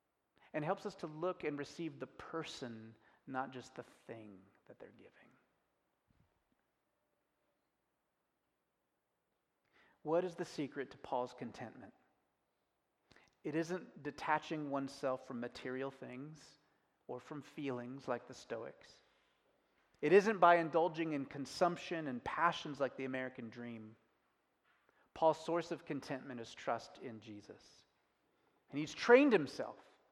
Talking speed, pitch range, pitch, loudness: 120 wpm, 125-165 Hz, 145 Hz, -38 LUFS